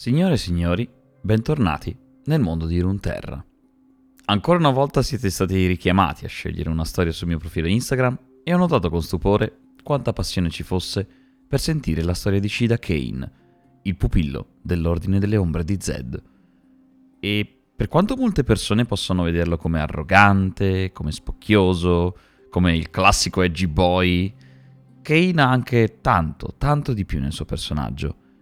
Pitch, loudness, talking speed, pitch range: 95 Hz, -21 LUFS, 150 wpm, 85-130 Hz